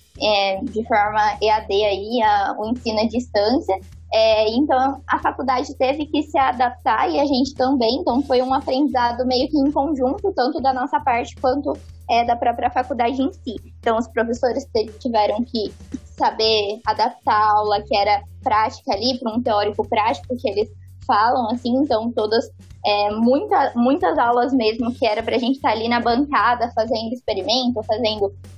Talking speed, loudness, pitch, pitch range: 170 wpm, -20 LUFS, 240 Hz, 215-265 Hz